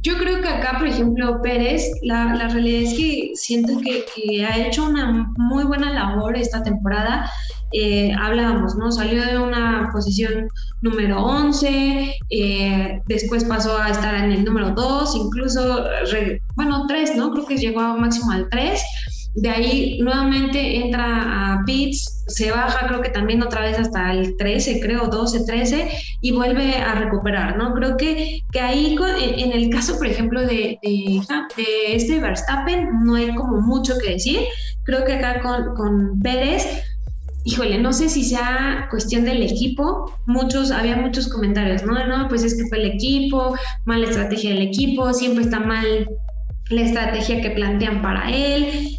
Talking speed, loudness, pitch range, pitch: 170 wpm, -20 LUFS, 220-260 Hz, 235 Hz